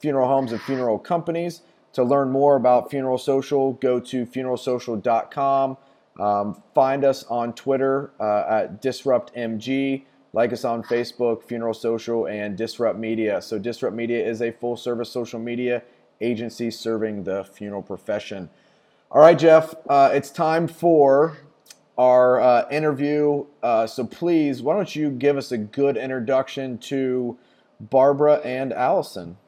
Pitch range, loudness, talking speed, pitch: 115-140 Hz, -21 LUFS, 140 wpm, 125 Hz